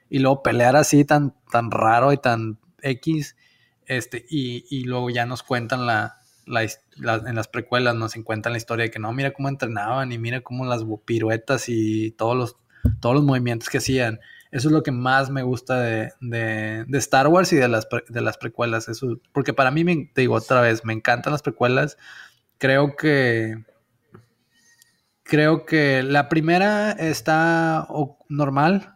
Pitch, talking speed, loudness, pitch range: 125 Hz, 175 wpm, -21 LUFS, 115-145 Hz